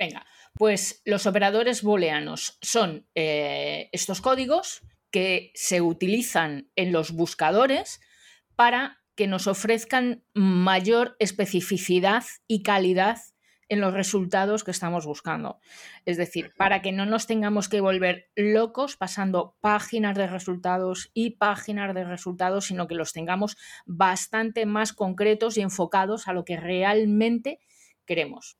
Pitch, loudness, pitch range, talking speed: 195 Hz, -25 LUFS, 180-220 Hz, 130 wpm